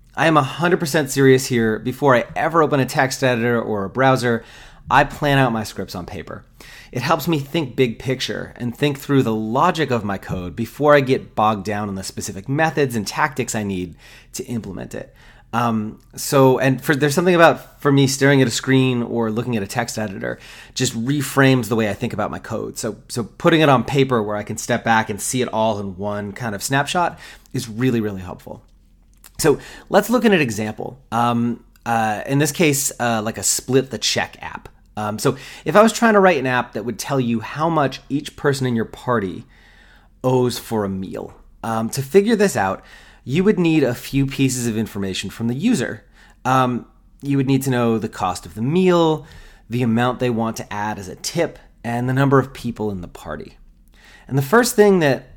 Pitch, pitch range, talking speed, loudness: 125 Hz, 110-140 Hz, 210 wpm, -19 LUFS